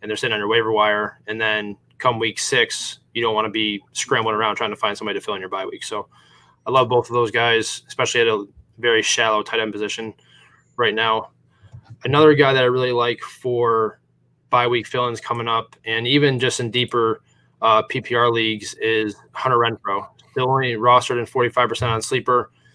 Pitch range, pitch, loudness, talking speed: 110-125 Hz, 115 Hz, -20 LUFS, 205 wpm